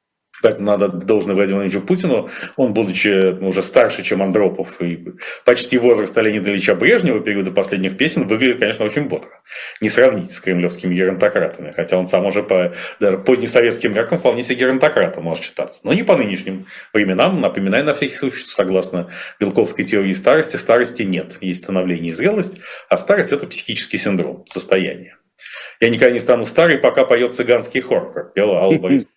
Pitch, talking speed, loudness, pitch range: 100 Hz, 165 wpm, -16 LUFS, 95-125 Hz